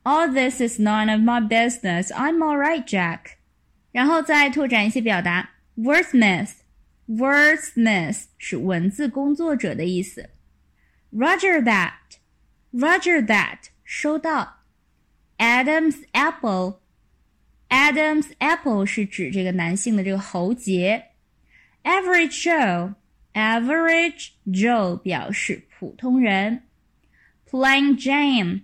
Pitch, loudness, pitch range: 235 Hz, -20 LUFS, 190-295 Hz